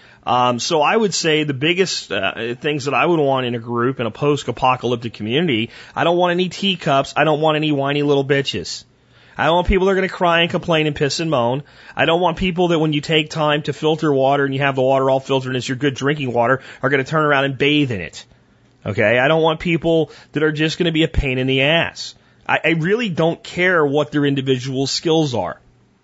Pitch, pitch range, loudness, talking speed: 145 Hz, 135-160 Hz, -18 LUFS, 245 wpm